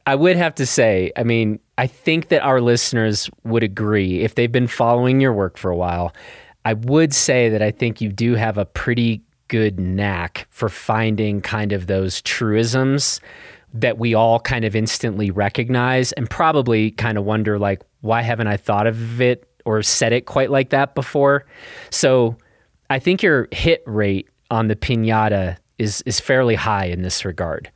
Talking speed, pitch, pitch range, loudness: 180 wpm, 115 Hz, 105-125 Hz, -18 LUFS